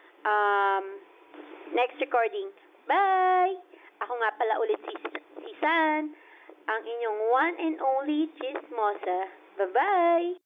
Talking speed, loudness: 105 wpm, -27 LUFS